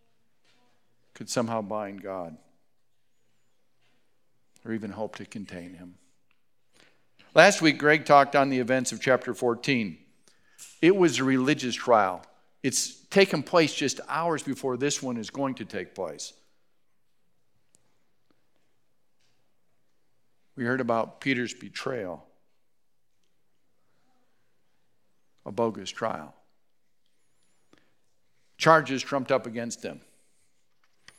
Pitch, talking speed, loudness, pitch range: 130 Hz, 100 wpm, -25 LUFS, 110-145 Hz